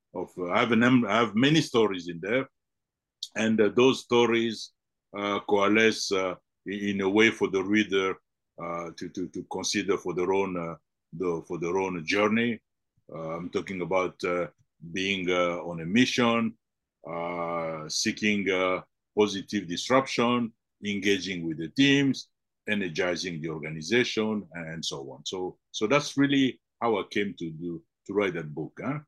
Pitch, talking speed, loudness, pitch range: 100 Hz, 160 wpm, -27 LUFS, 85-115 Hz